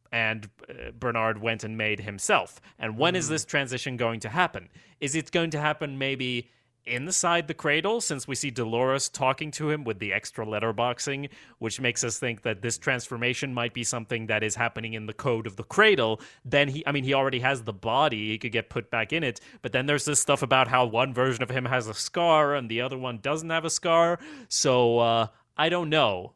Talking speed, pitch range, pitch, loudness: 220 wpm, 115-150 Hz, 125 Hz, -26 LUFS